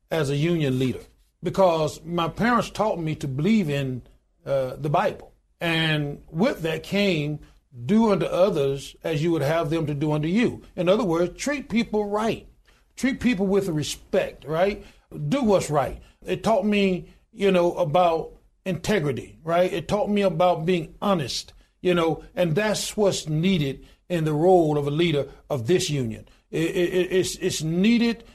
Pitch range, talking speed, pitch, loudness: 155-195 Hz, 165 wpm, 175 Hz, -24 LUFS